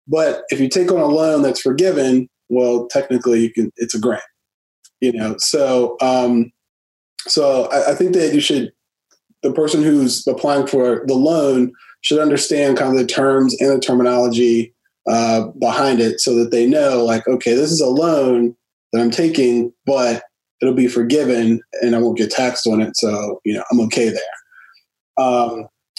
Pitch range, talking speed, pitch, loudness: 115-135 Hz, 175 wpm, 125 Hz, -16 LUFS